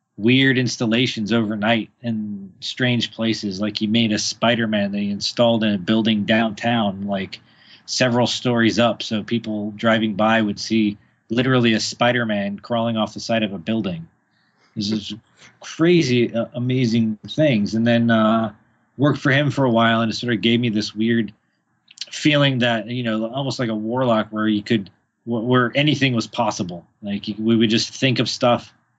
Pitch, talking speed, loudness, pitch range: 115 Hz, 170 wpm, -20 LUFS, 105-120 Hz